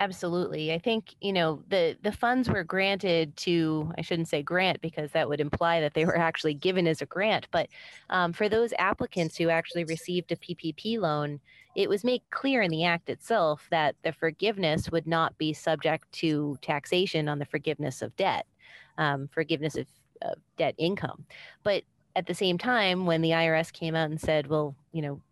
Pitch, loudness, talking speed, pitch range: 165 Hz, -28 LUFS, 190 wpm, 155-185 Hz